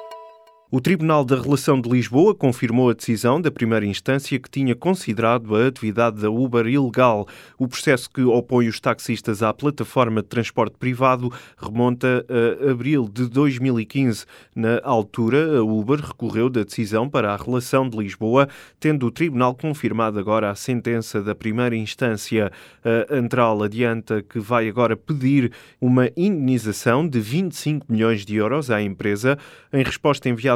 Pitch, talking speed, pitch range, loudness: 120 Hz, 150 wpm, 110-135 Hz, -21 LUFS